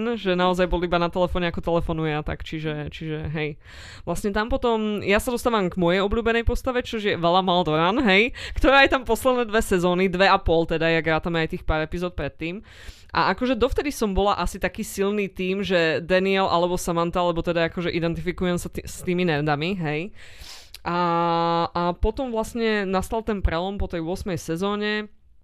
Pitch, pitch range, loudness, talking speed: 180 Hz, 170-210 Hz, -23 LUFS, 185 wpm